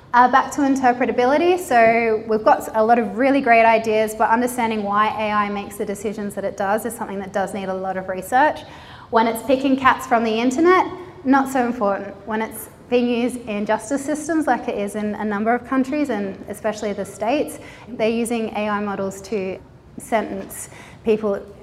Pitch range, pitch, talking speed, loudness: 205-245 Hz, 225 Hz, 190 wpm, -20 LUFS